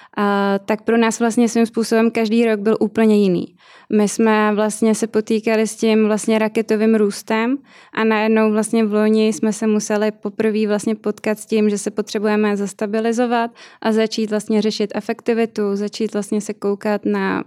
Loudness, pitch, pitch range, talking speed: -18 LUFS, 220 Hz, 210-225 Hz, 170 wpm